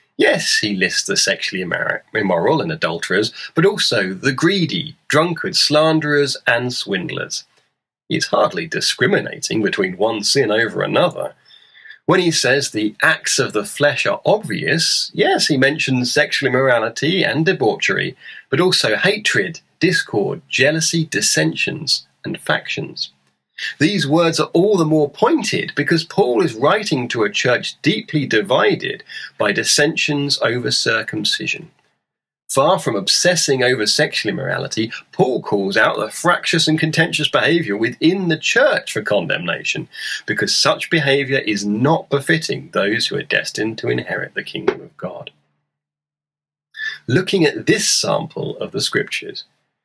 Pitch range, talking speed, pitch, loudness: 125-160 Hz, 135 wpm, 145 Hz, -17 LUFS